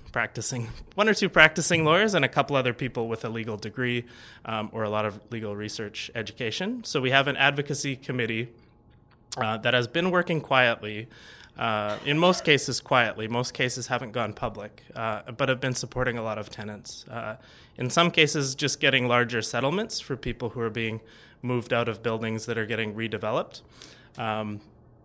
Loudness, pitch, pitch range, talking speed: -26 LUFS, 120 Hz, 110-135 Hz, 180 wpm